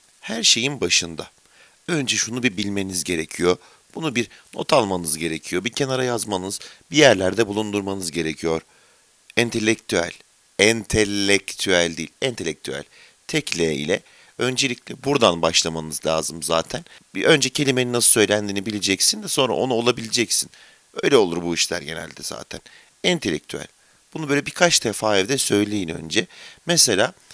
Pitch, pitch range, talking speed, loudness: 105 Hz, 85-125 Hz, 125 wpm, -20 LUFS